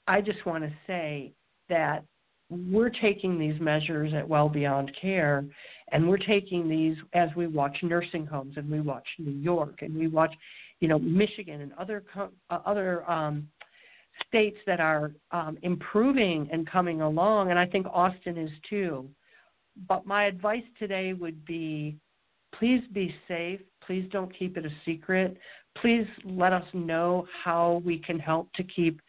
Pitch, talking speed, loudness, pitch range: 175 Hz, 160 wpm, -29 LUFS, 155-190 Hz